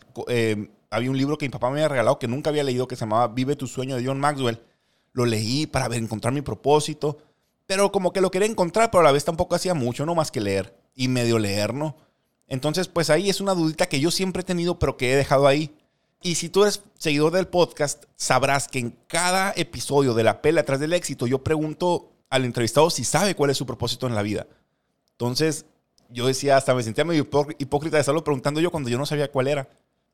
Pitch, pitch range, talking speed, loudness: 145 Hz, 125-160 Hz, 230 wpm, -23 LUFS